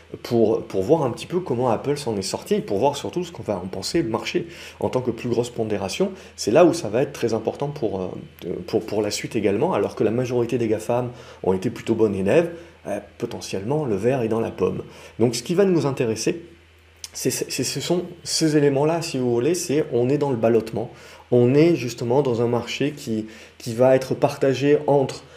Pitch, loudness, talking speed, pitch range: 125 Hz, -22 LUFS, 220 wpm, 115-145 Hz